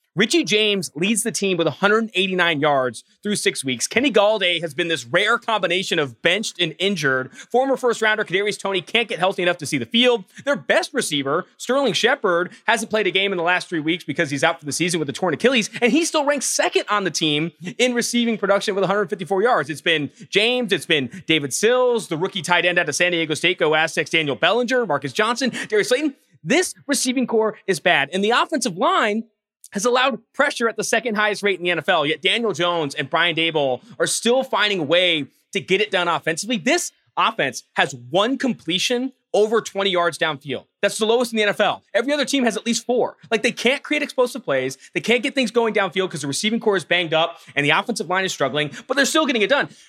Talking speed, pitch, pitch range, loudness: 225 wpm, 200 Hz, 170-240 Hz, -20 LUFS